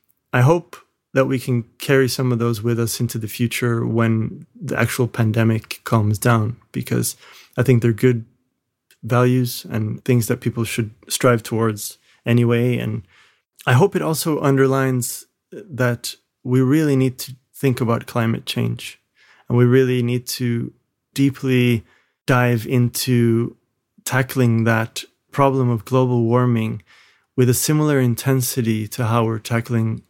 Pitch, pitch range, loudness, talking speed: 120 Hz, 115-130 Hz, -19 LUFS, 140 wpm